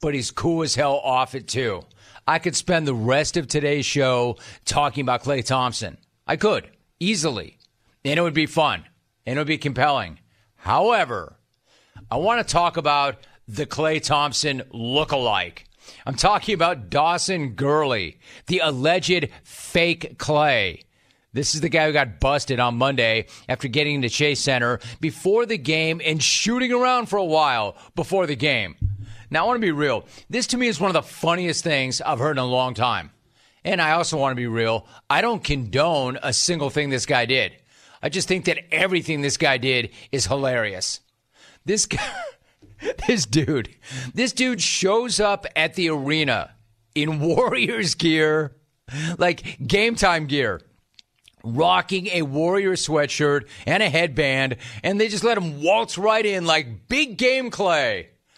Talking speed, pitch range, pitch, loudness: 165 wpm, 130-175 Hz, 150 Hz, -21 LUFS